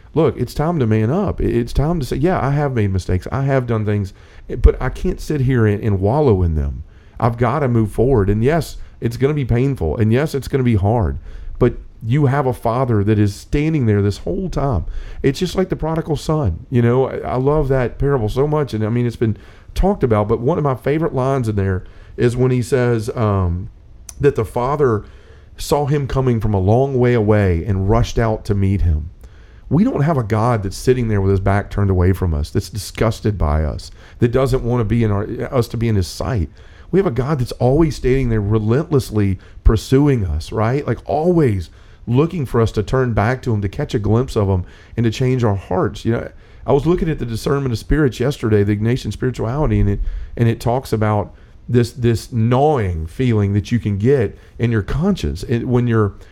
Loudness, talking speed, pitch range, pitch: -18 LUFS, 225 wpm, 100-135 Hz, 115 Hz